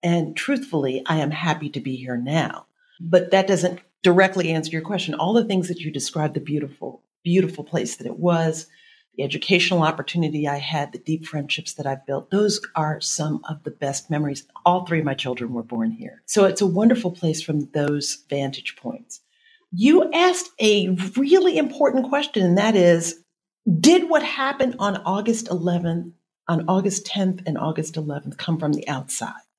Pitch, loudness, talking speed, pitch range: 175 Hz, -22 LUFS, 180 wpm, 150-205 Hz